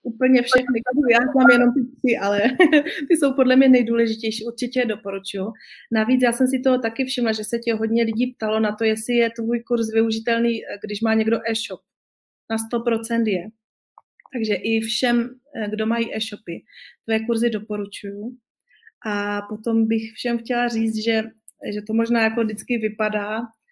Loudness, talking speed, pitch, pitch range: -21 LUFS, 165 wpm, 230 Hz, 220-245 Hz